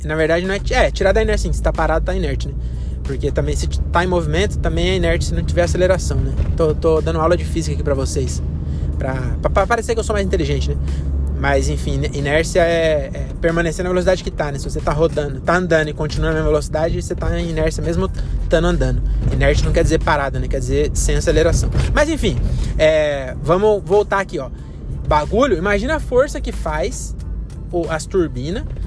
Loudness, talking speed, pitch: -18 LUFS, 210 wpm, 145 Hz